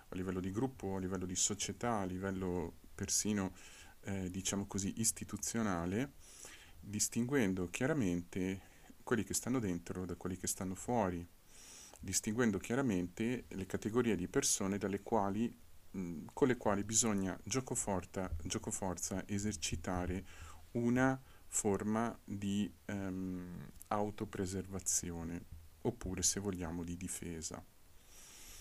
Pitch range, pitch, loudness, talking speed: 90-105 Hz, 95 Hz, -38 LUFS, 115 wpm